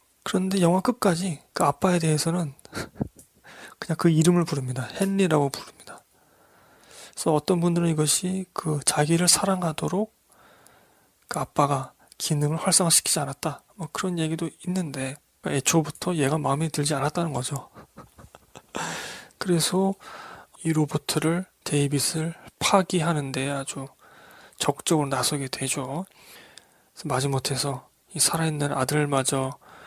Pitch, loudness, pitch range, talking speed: 155 Hz, -25 LUFS, 140-175 Hz, 280 characters per minute